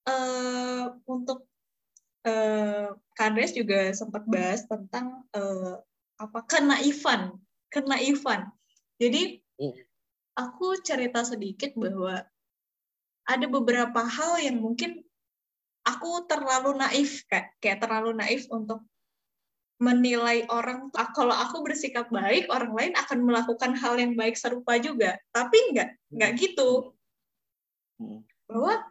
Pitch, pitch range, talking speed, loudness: 245 Hz, 225-270 Hz, 110 wpm, -27 LUFS